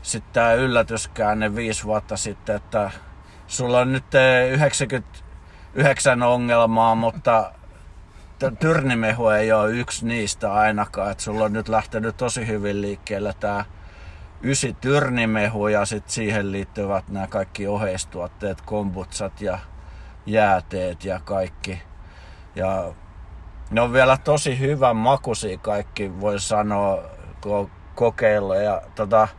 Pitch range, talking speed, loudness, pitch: 95-115 Hz, 110 wpm, -22 LUFS, 105 Hz